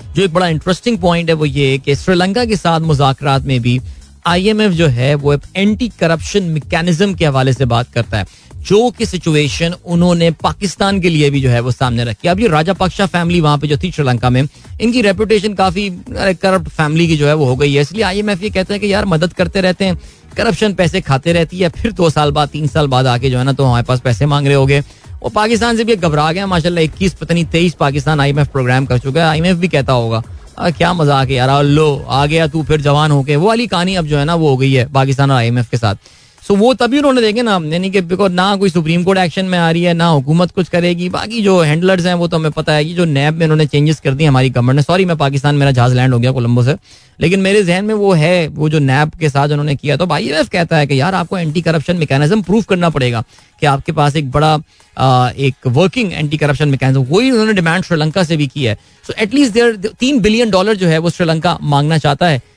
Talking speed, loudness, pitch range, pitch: 245 wpm, -13 LUFS, 140-185 Hz, 160 Hz